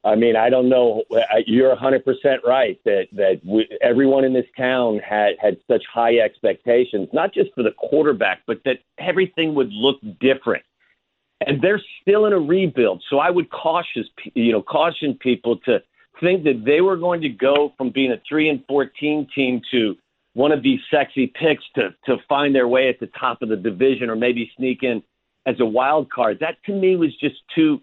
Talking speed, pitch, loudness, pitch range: 195 wpm, 135 Hz, -19 LUFS, 120-155 Hz